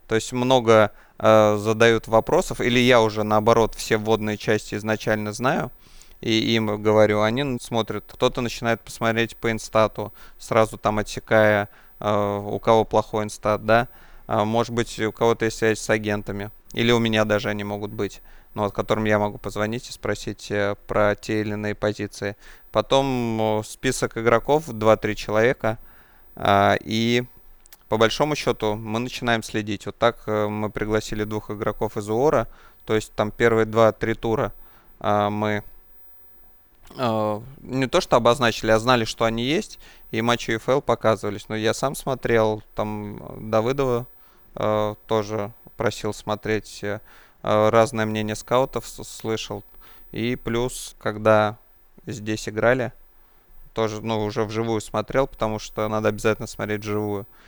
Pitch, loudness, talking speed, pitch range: 110 Hz, -23 LUFS, 145 wpm, 105-115 Hz